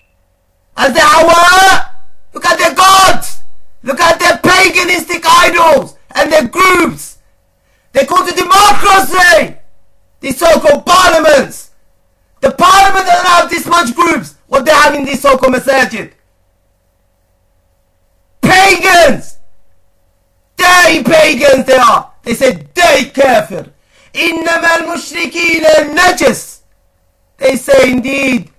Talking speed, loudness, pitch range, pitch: 105 wpm, -8 LUFS, 235-345 Hz, 305 Hz